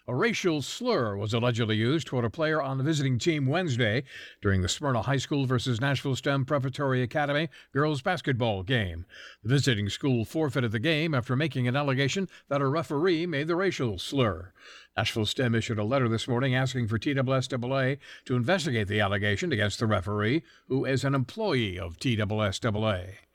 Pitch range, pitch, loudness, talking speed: 110-140 Hz, 130 Hz, -28 LUFS, 170 wpm